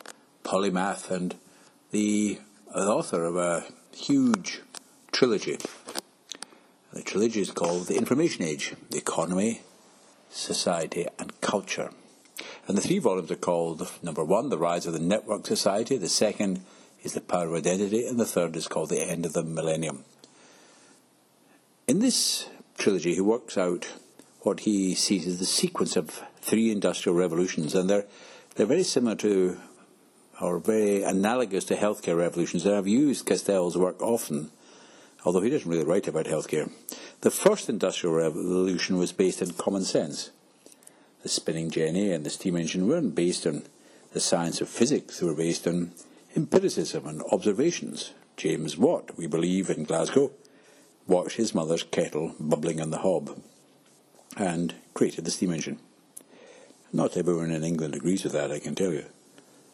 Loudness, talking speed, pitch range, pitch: -27 LUFS, 155 wpm, 85-100 Hz, 90 Hz